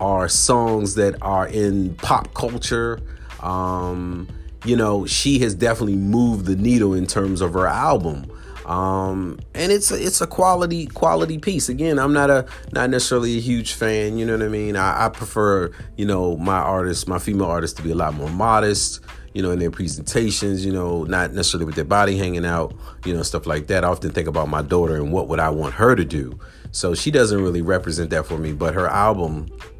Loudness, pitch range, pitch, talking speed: -20 LUFS, 85-115 Hz, 95 Hz, 210 wpm